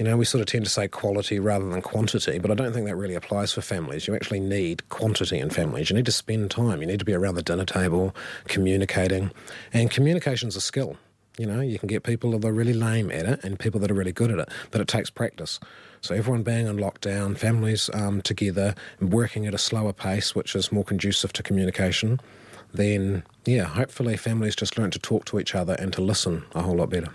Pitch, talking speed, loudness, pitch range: 105 Hz, 235 wpm, -25 LUFS, 95-115 Hz